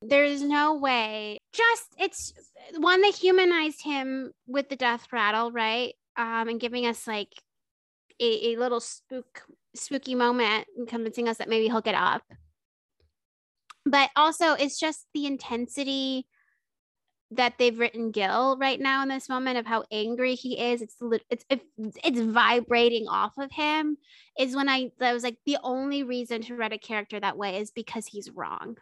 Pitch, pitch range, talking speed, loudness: 245 Hz, 230-275 Hz, 165 wpm, -26 LUFS